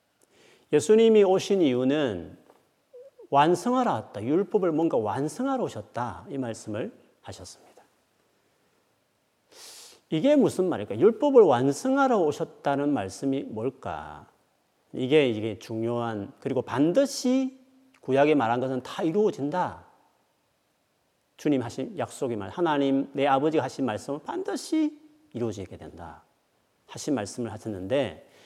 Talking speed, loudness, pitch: 265 characters per minute, -26 LUFS, 145 Hz